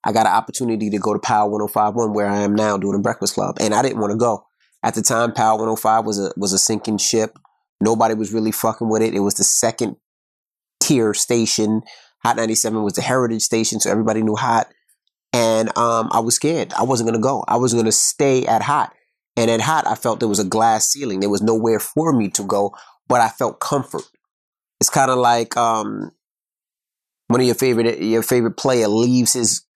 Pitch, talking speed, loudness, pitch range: 110 Hz, 215 wpm, -18 LUFS, 105-120 Hz